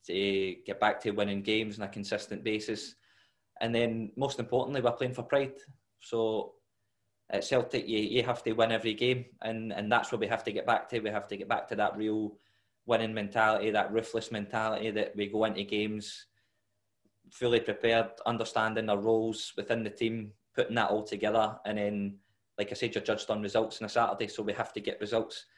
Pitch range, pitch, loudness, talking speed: 105-115 Hz, 110 Hz, -32 LUFS, 195 wpm